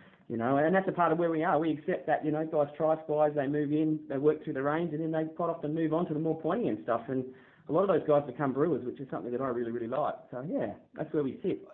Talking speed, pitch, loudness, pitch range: 310 wpm, 150 Hz, -31 LUFS, 140-160 Hz